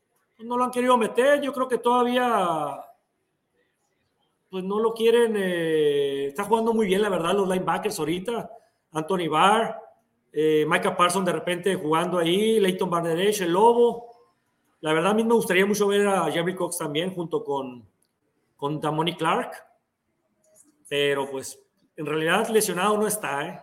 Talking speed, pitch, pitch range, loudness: 155 wpm, 190 Hz, 160-220 Hz, -23 LUFS